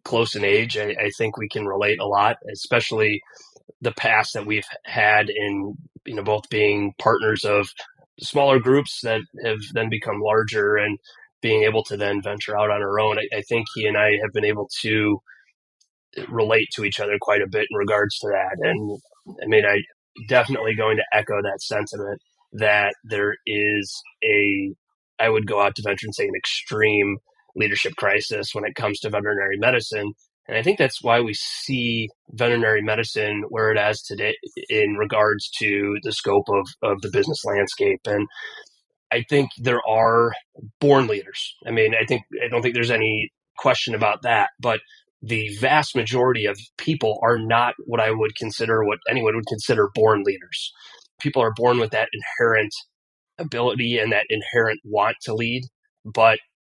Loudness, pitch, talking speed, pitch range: -21 LUFS, 110 Hz, 180 wpm, 105-125 Hz